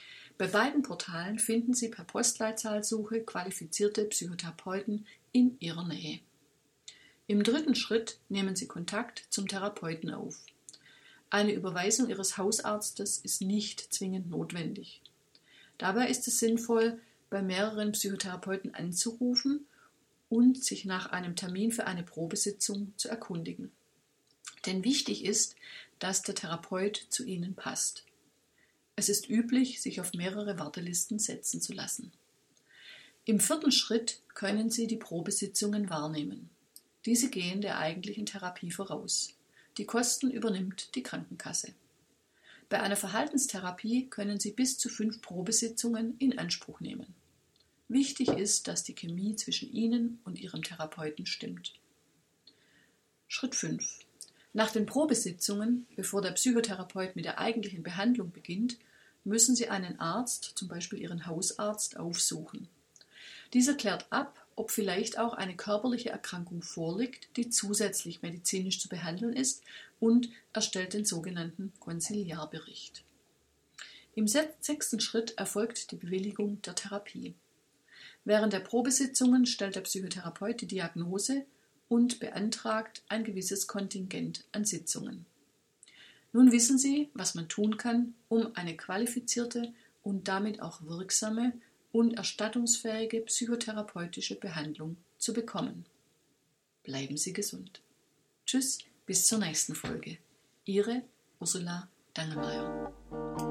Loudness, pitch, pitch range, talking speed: -32 LUFS, 210 Hz, 185-235 Hz, 120 wpm